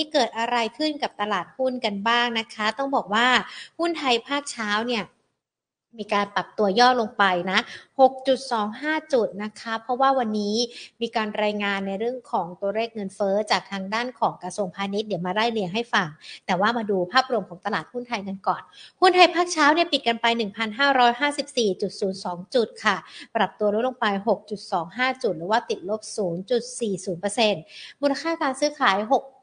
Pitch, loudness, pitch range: 225 Hz, -24 LUFS, 200-255 Hz